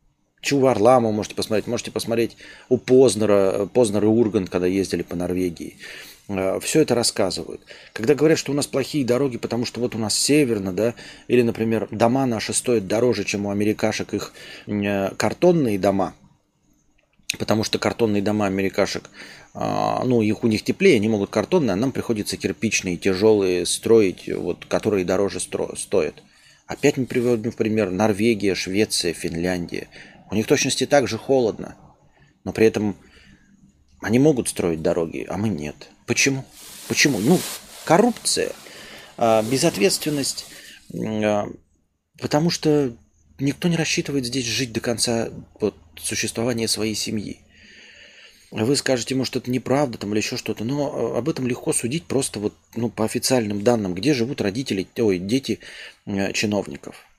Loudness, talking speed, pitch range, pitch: -21 LUFS, 140 wpm, 100-125 Hz, 110 Hz